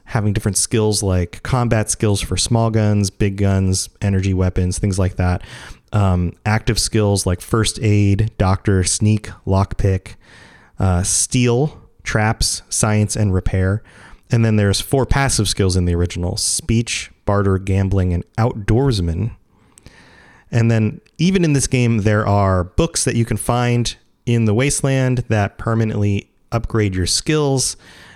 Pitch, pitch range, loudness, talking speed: 105 Hz, 95-115 Hz, -18 LUFS, 140 wpm